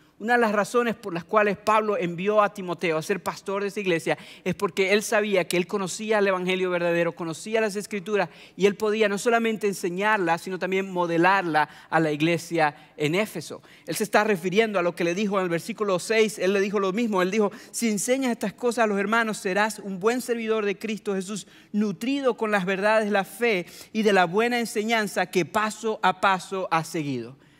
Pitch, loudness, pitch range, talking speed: 200 Hz, -24 LUFS, 180-215 Hz, 210 wpm